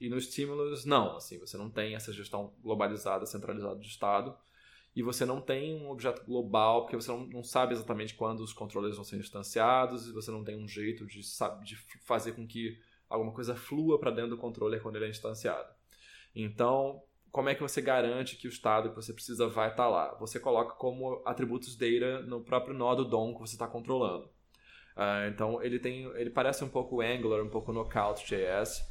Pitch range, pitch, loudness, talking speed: 110-125 Hz, 115 Hz, -34 LUFS, 200 wpm